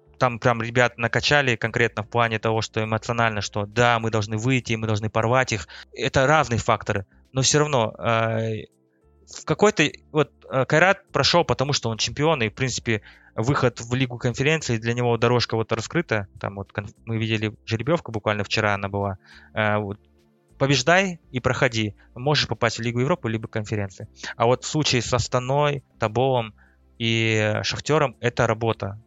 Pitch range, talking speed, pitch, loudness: 110-130 Hz, 165 wpm, 115 Hz, -23 LUFS